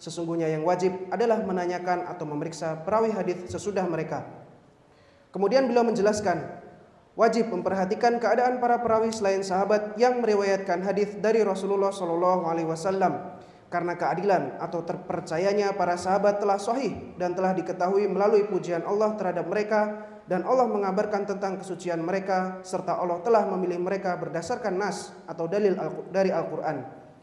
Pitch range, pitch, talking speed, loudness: 175-205 Hz, 185 Hz, 135 wpm, -26 LUFS